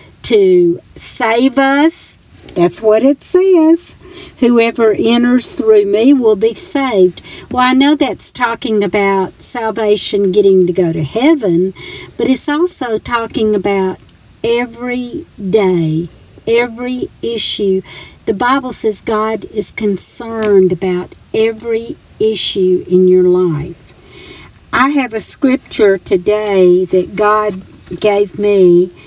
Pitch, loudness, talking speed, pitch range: 215 Hz, -12 LUFS, 115 wpm, 190-245 Hz